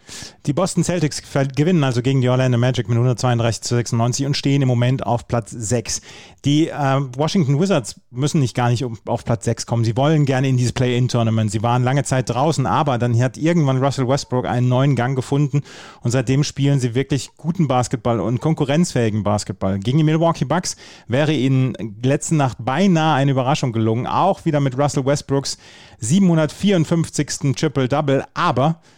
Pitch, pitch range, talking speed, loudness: 135 Hz, 120-150 Hz, 170 wpm, -19 LUFS